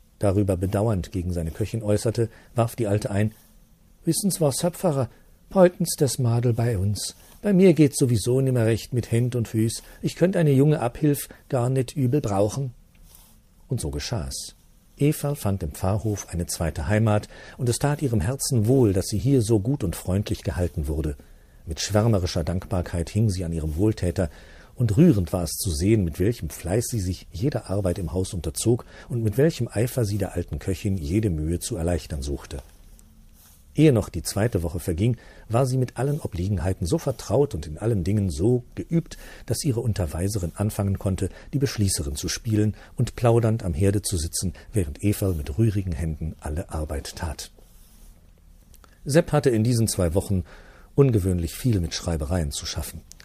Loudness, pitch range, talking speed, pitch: -24 LUFS, 85-120 Hz, 175 wpm, 105 Hz